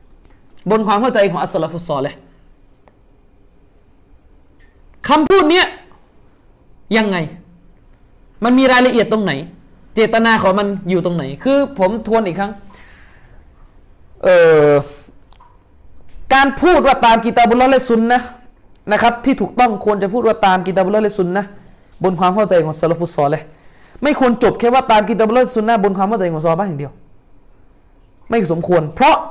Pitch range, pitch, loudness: 170-240 Hz, 205 Hz, -14 LUFS